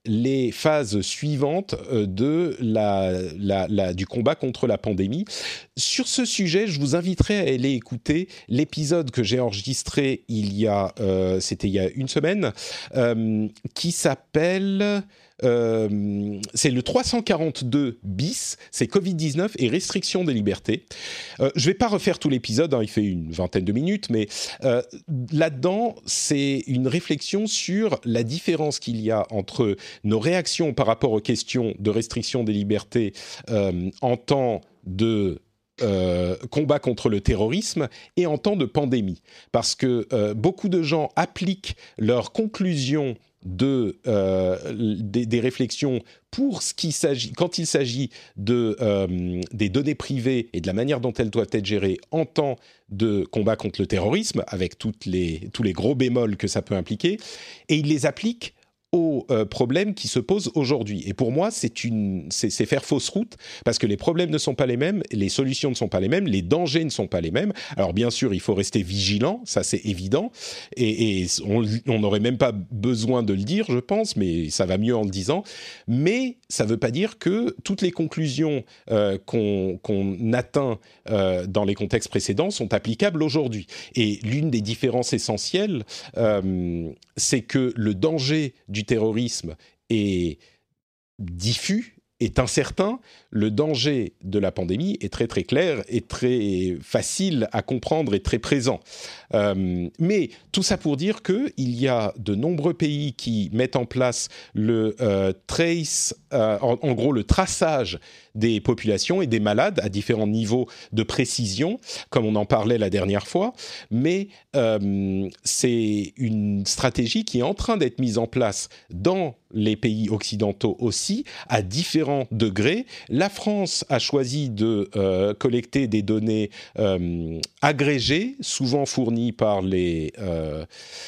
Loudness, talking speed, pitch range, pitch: -24 LUFS, 165 wpm, 105-150 Hz, 120 Hz